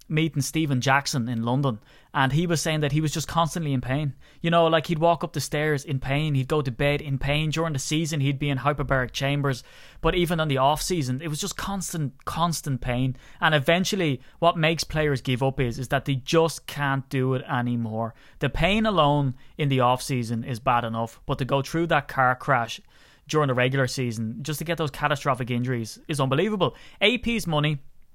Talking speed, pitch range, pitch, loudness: 210 wpm, 130-160 Hz, 145 Hz, -25 LUFS